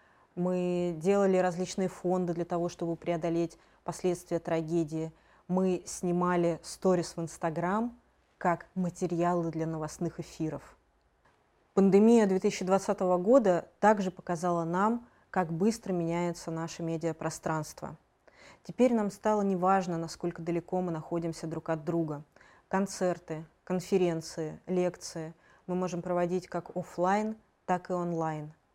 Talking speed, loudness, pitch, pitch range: 110 wpm, -31 LUFS, 175 Hz, 165-185 Hz